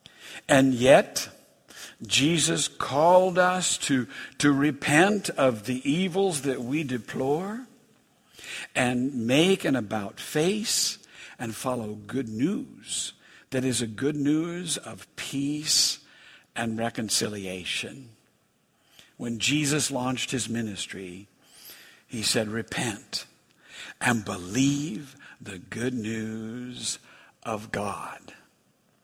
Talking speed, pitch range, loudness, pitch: 95 wpm, 115-150 Hz, -26 LUFS, 130 Hz